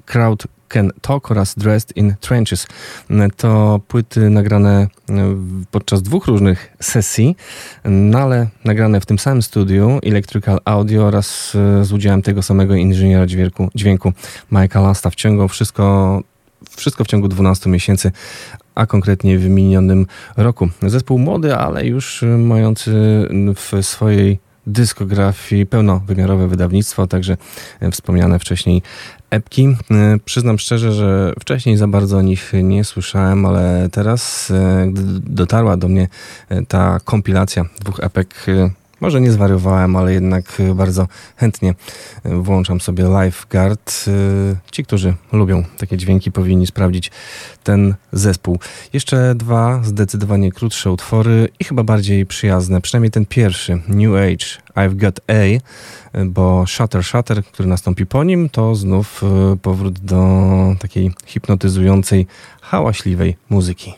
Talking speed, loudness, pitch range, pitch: 120 wpm, -15 LUFS, 95-110 Hz, 100 Hz